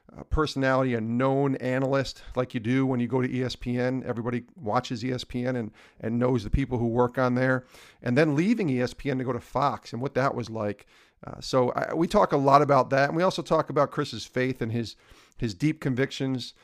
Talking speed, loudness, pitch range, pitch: 215 wpm, -26 LUFS, 125-140 Hz, 130 Hz